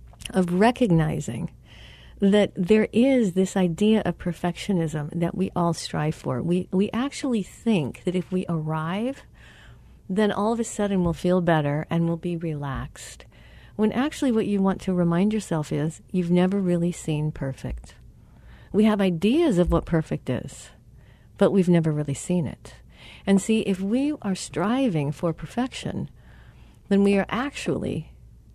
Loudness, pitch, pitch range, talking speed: -24 LUFS, 180 Hz, 160-210 Hz, 155 wpm